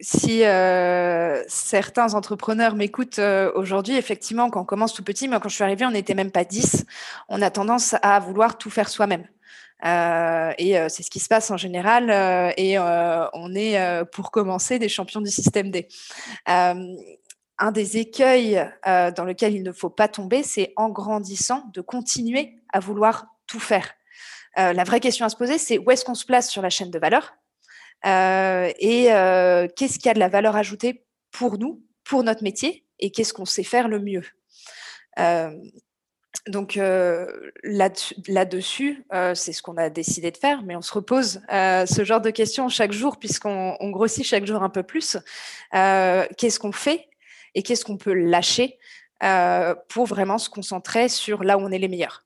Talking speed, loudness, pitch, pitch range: 195 wpm, -22 LUFS, 205 Hz, 185-230 Hz